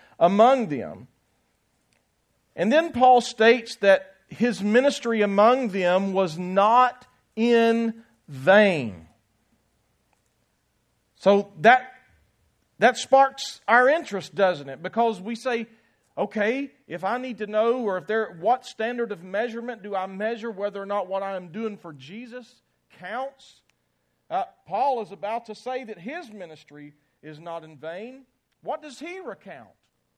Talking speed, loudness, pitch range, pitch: 135 wpm, -23 LUFS, 190-250 Hz, 220 Hz